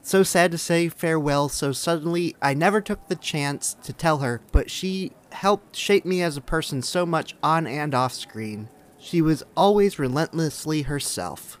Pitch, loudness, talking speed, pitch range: 160 Hz, -23 LUFS, 175 wpm, 140-175 Hz